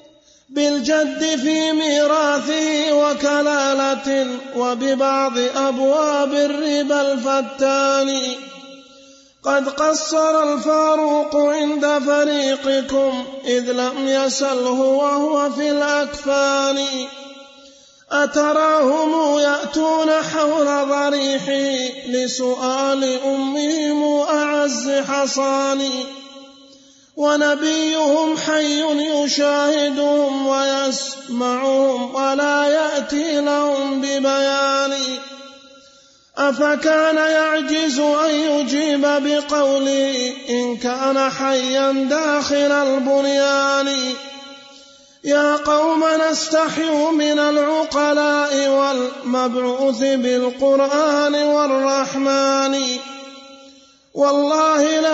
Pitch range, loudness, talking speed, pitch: 275-295 Hz, -18 LUFS, 60 wpm, 280 Hz